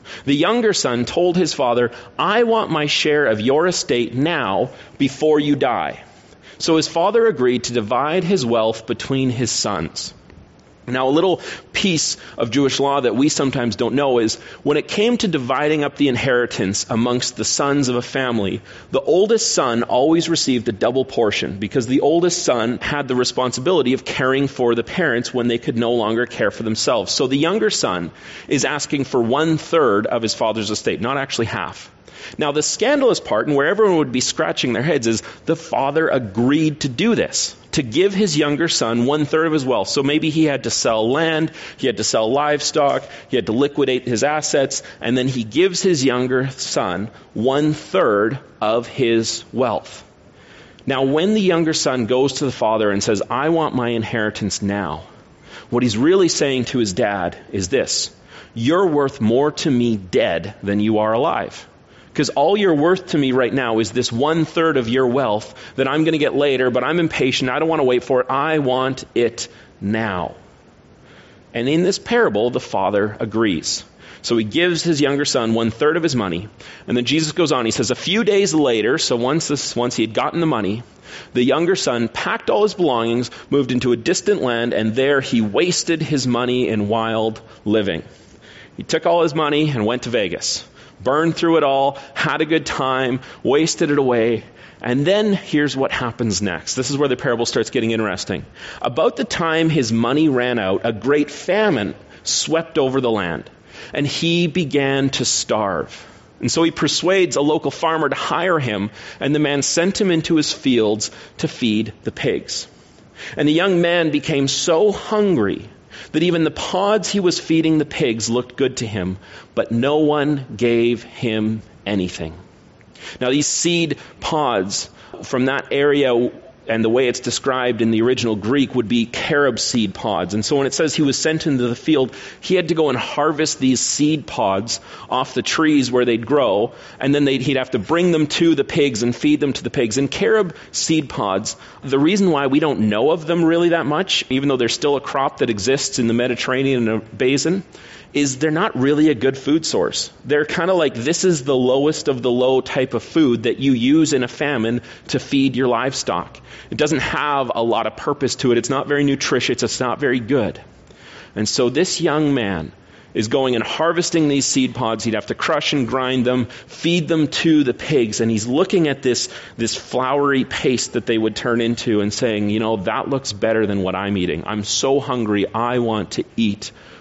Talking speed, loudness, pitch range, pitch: 195 wpm, -18 LUFS, 115-155 Hz, 130 Hz